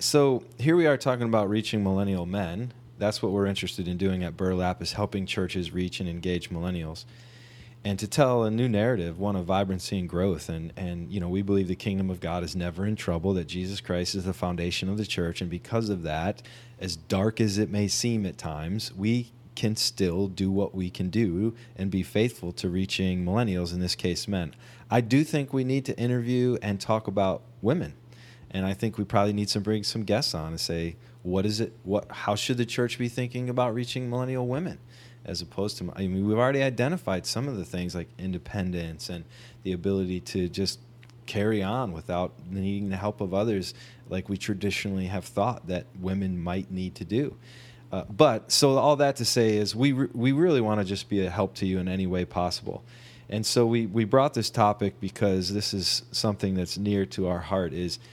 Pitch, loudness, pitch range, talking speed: 100 Hz, -28 LUFS, 95-120 Hz, 210 wpm